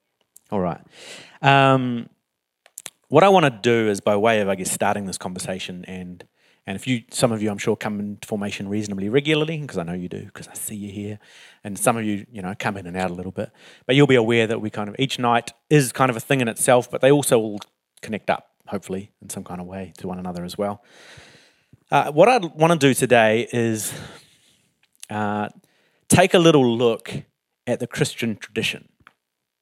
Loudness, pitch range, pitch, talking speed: -21 LUFS, 100-130 Hz, 110 Hz, 215 wpm